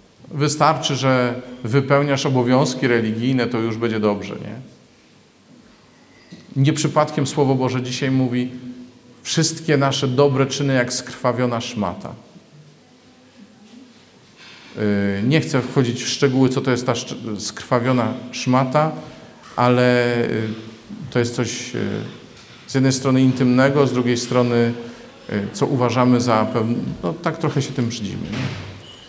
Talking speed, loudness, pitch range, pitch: 115 wpm, -19 LUFS, 120-140 Hz, 125 Hz